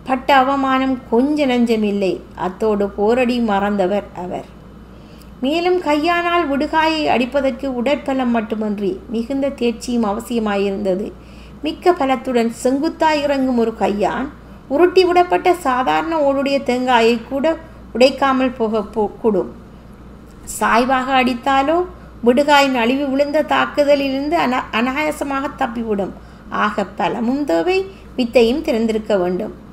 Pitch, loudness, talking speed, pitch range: 260 Hz, -17 LUFS, 95 wpm, 225-285 Hz